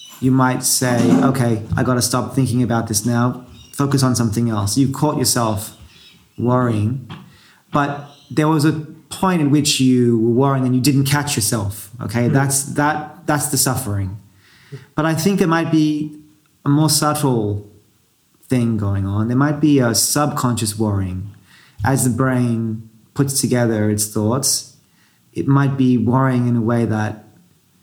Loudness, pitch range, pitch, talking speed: -17 LUFS, 115-145 Hz, 125 Hz, 160 wpm